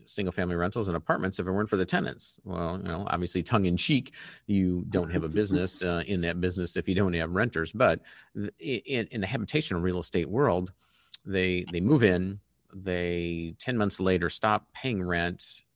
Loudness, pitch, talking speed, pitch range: -28 LUFS, 90 Hz, 200 wpm, 85-95 Hz